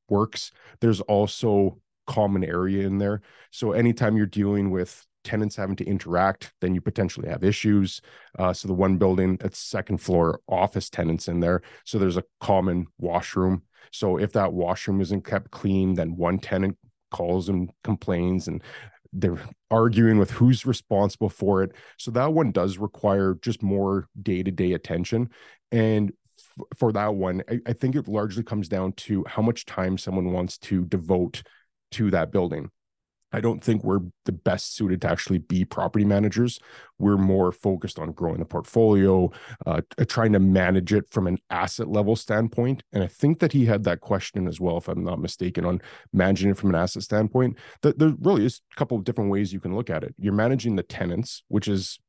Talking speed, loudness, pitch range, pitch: 185 wpm, -24 LUFS, 95-110 Hz, 100 Hz